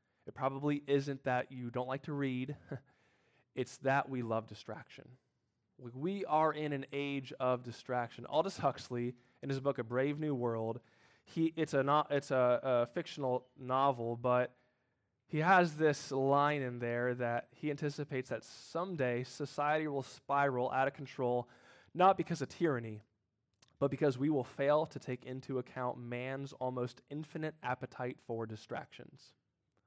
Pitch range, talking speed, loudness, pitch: 125-145 Hz, 155 wpm, -36 LUFS, 130 Hz